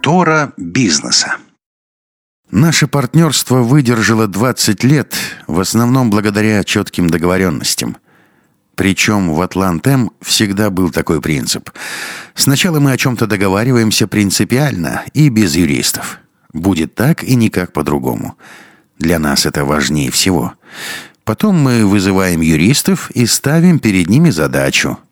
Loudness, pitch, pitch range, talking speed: -12 LUFS, 110 Hz, 95-135 Hz, 110 wpm